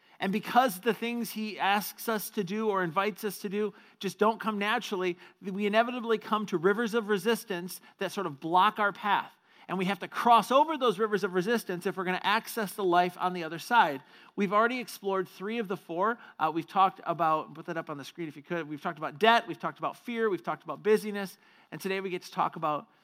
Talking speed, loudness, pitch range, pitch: 235 wpm, -29 LUFS, 180-220 Hz, 200 Hz